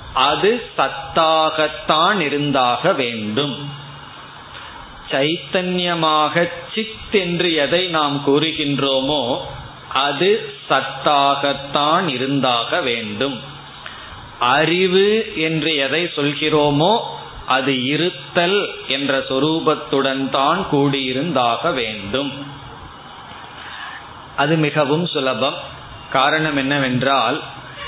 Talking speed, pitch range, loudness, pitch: 50 wpm, 135-165 Hz, -18 LUFS, 145 Hz